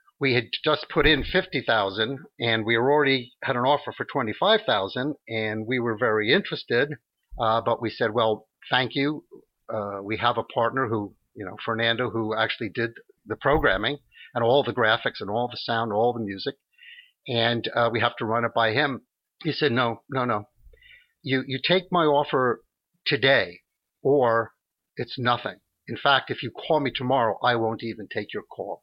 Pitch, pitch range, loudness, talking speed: 120 Hz, 110-140 Hz, -24 LUFS, 185 wpm